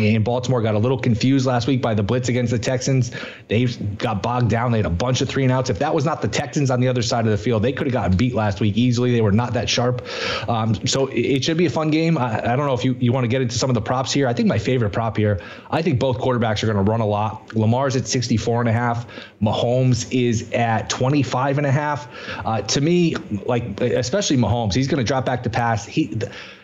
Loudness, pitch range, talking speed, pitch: -20 LUFS, 110-130 Hz, 270 wpm, 125 Hz